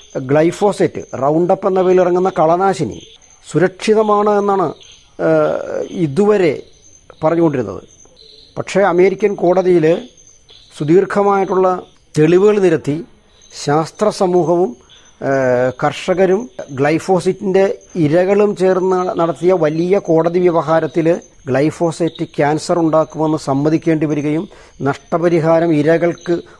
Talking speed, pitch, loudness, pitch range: 75 wpm, 170 Hz, -15 LUFS, 155-190 Hz